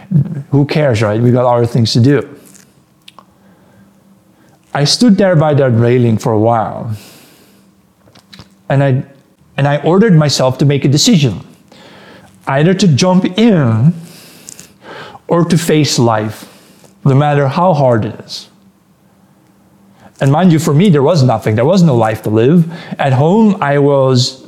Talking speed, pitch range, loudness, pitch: 145 wpm, 125-170 Hz, -11 LUFS, 140 Hz